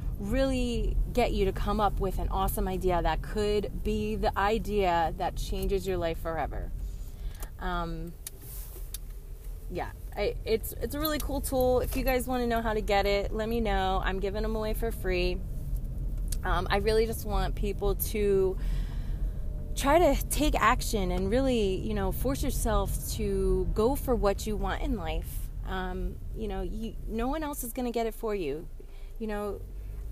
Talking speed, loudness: 175 wpm, -30 LUFS